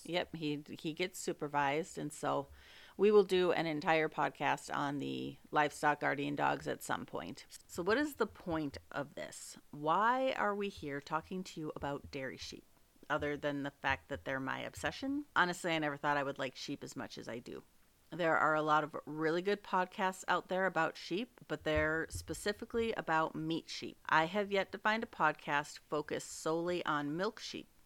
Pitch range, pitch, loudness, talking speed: 150-185 Hz, 160 Hz, -36 LUFS, 190 wpm